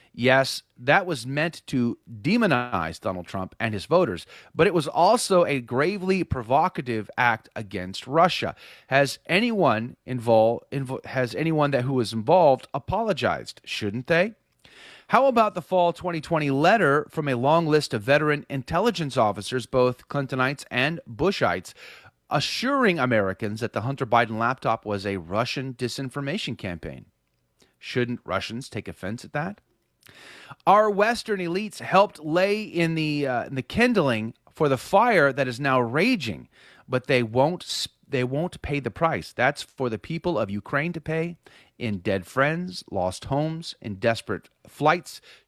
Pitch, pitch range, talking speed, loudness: 135 Hz, 115-165 Hz, 150 wpm, -24 LUFS